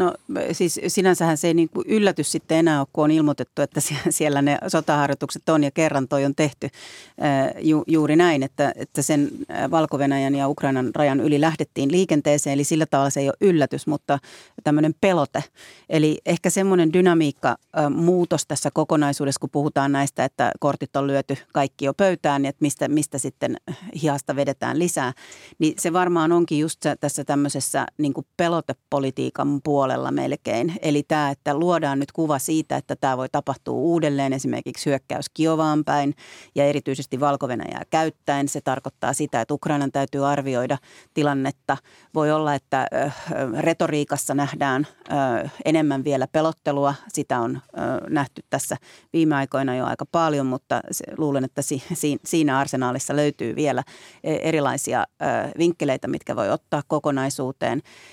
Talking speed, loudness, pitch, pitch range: 145 wpm, -22 LUFS, 145 Hz, 140-160 Hz